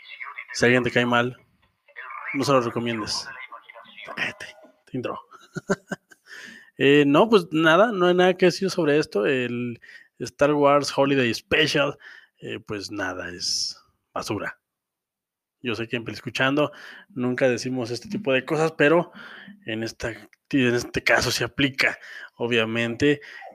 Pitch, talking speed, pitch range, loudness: 130 Hz, 140 wpm, 120-150 Hz, -23 LUFS